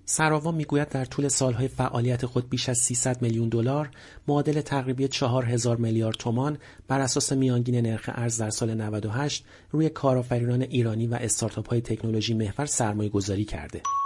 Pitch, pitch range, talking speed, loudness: 125 Hz, 115-140 Hz, 155 wpm, -26 LUFS